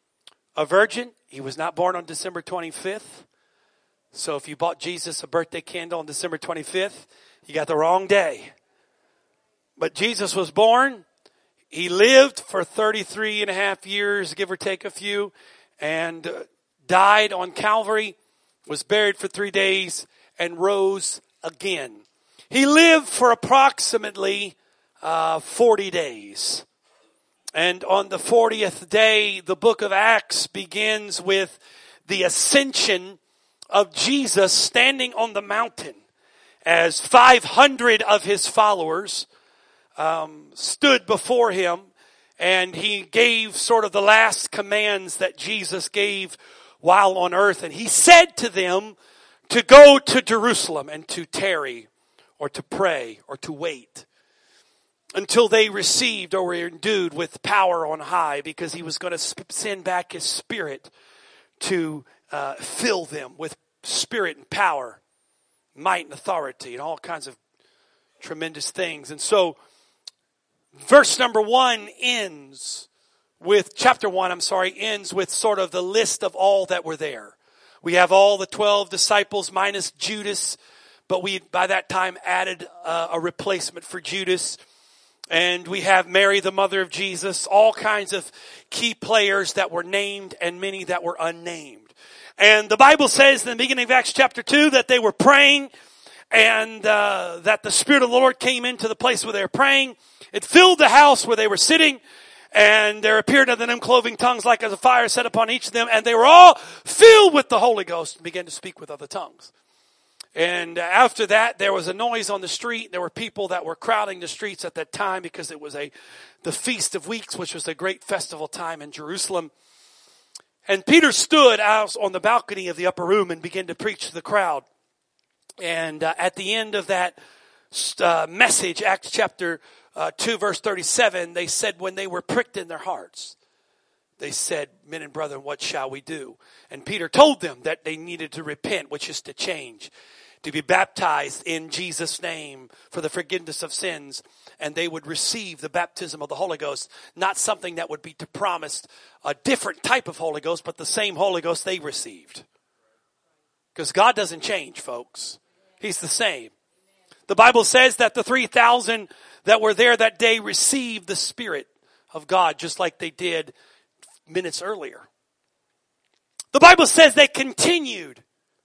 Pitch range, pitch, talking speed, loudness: 180-240 Hz, 200 Hz, 165 wpm, -19 LUFS